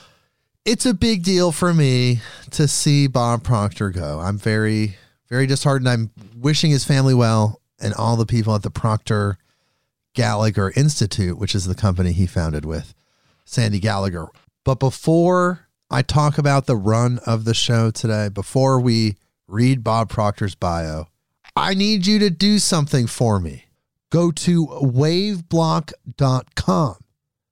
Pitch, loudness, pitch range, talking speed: 120 Hz, -19 LUFS, 105-145 Hz, 145 wpm